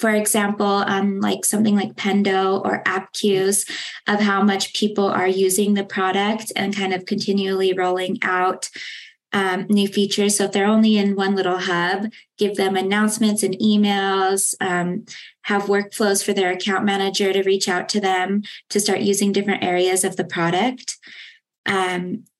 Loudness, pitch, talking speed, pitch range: -20 LUFS, 195 Hz, 165 wpm, 190-205 Hz